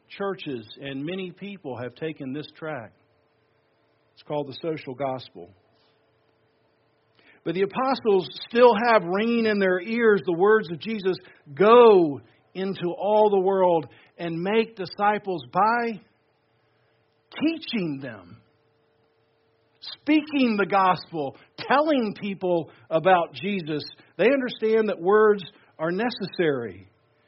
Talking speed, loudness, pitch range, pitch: 110 wpm, -23 LUFS, 145-205 Hz, 175 Hz